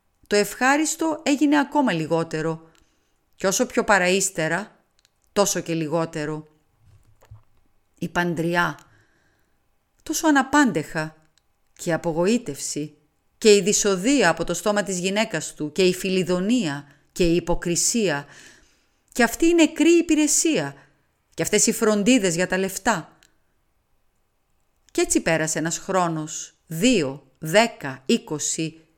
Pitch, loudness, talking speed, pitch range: 180 Hz, -21 LUFS, 110 wpm, 160-230 Hz